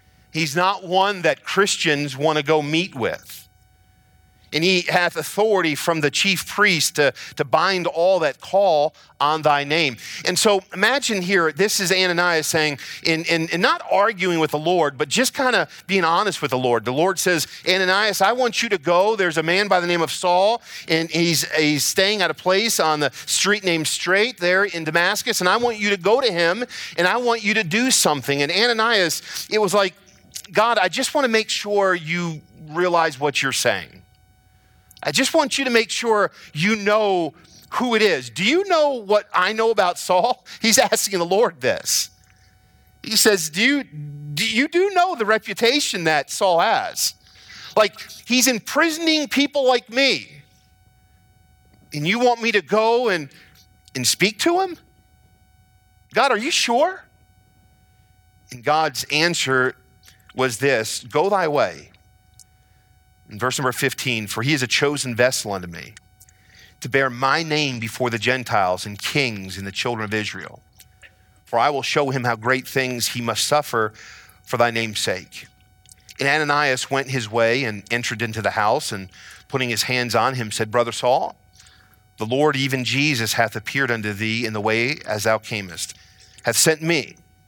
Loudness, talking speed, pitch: -19 LUFS, 180 wpm, 150 Hz